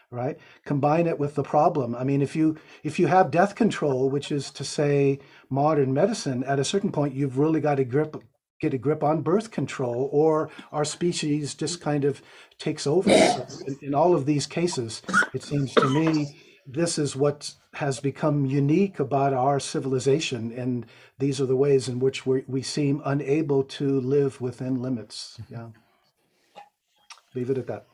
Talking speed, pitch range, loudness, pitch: 180 wpm, 135-155 Hz, -25 LUFS, 140 Hz